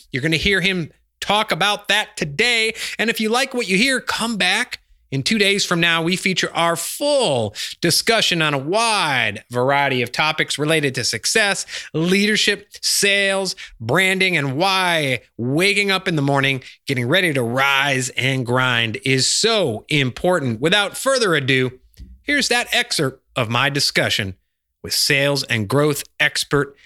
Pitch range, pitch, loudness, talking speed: 135-200 Hz, 160 Hz, -18 LUFS, 155 wpm